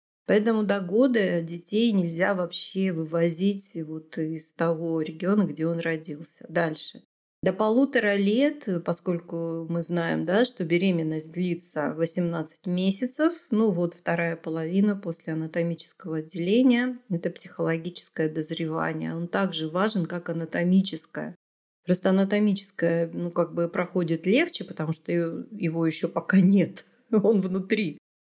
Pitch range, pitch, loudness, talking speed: 165-195 Hz, 175 Hz, -26 LUFS, 120 wpm